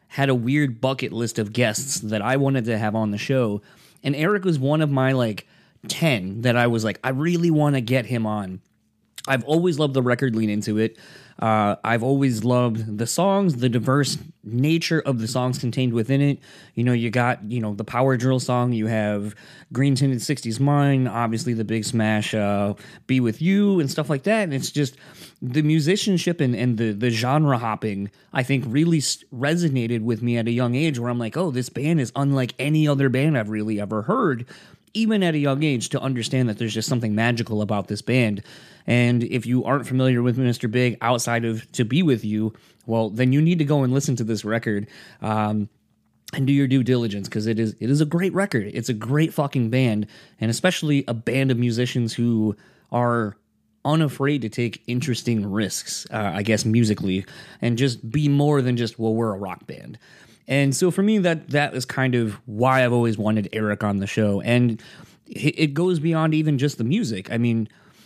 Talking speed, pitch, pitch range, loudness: 205 wpm, 125 Hz, 110-140 Hz, -22 LUFS